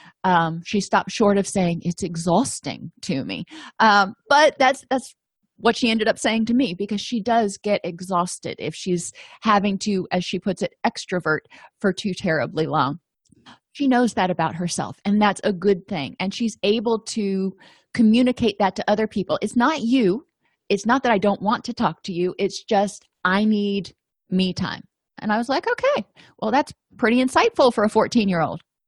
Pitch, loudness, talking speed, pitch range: 200 Hz, -21 LUFS, 185 wpm, 185-230 Hz